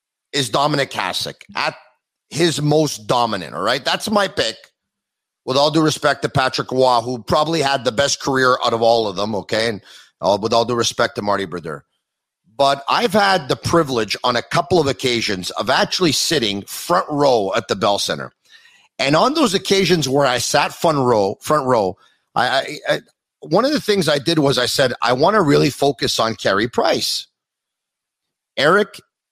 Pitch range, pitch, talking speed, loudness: 120-170 Hz, 140 Hz, 185 wpm, -17 LUFS